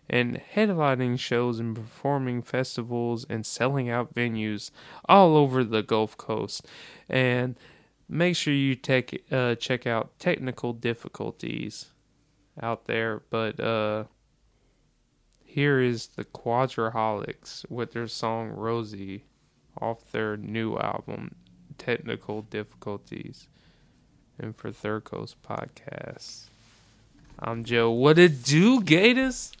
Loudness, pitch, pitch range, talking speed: -26 LUFS, 120 Hz, 110-130 Hz, 110 wpm